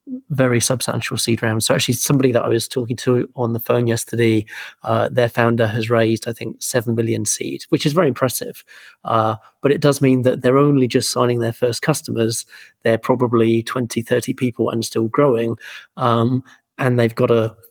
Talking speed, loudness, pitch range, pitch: 190 wpm, -18 LUFS, 115-130 Hz, 120 Hz